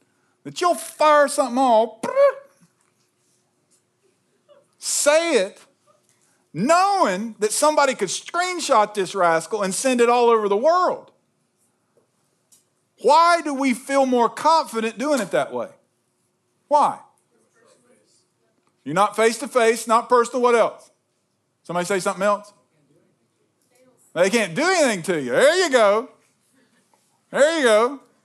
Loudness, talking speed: -19 LUFS, 120 wpm